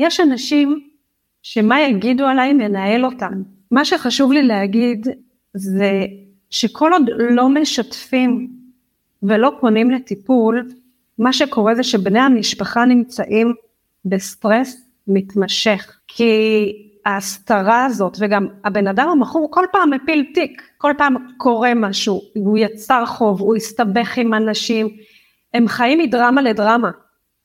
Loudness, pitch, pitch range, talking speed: -16 LUFS, 235 Hz, 210-255 Hz, 115 wpm